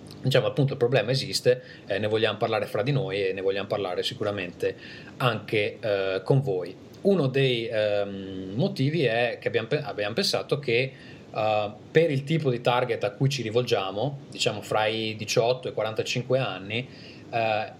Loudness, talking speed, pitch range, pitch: -26 LUFS, 170 wpm, 110-145 Hz, 125 Hz